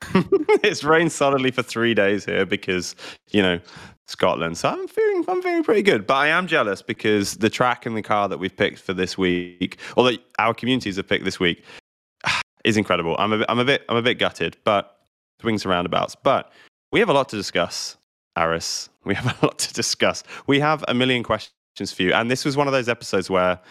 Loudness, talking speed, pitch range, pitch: -21 LUFS, 220 wpm, 95-135 Hz, 110 Hz